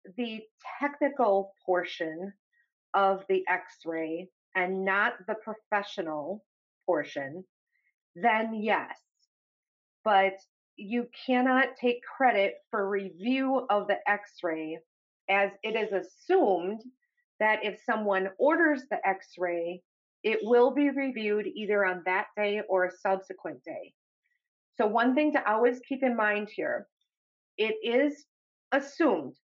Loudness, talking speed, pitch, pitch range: -29 LUFS, 120 wpm, 210 Hz, 190-255 Hz